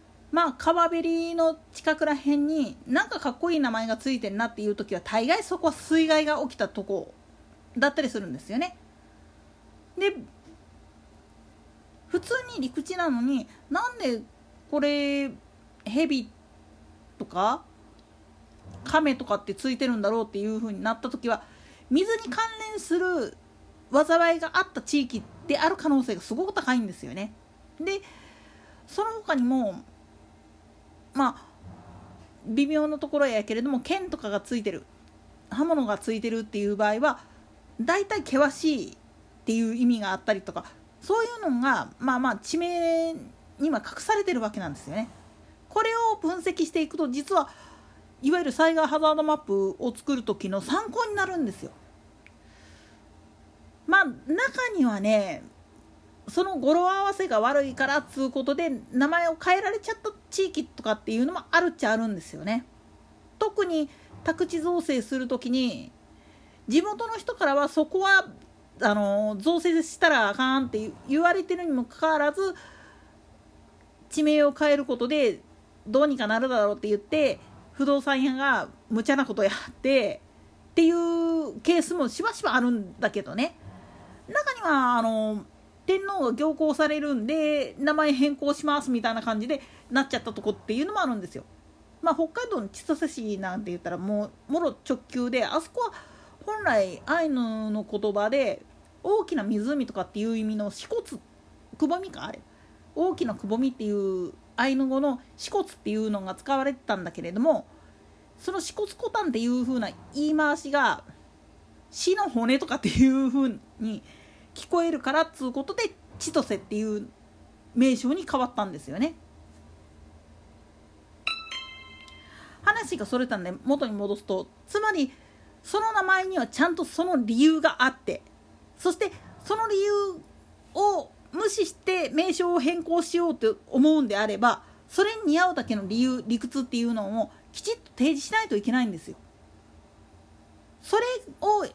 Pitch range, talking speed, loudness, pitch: 220-330 Hz, 305 characters per minute, -26 LUFS, 275 Hz